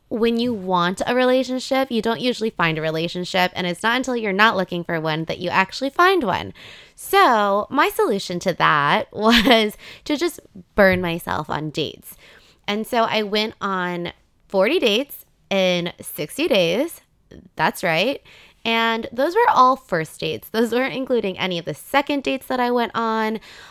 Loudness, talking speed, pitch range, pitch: -20 LUFS, 170 wpm, 185-255 Hz, 225 Hz